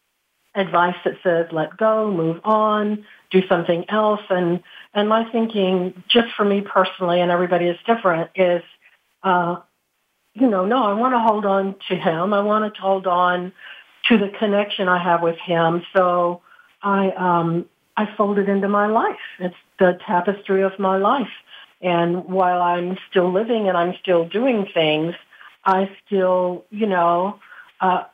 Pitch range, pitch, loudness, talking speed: 175-205 Hz, 185 Hz, -20 LUFS, 160 wpm